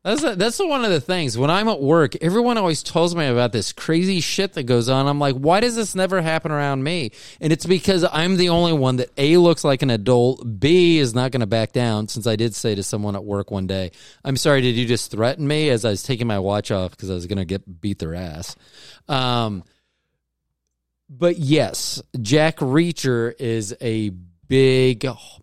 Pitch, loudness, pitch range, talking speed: 130 Hz, -20 LUFS, 110-160 Hz, 215 wpm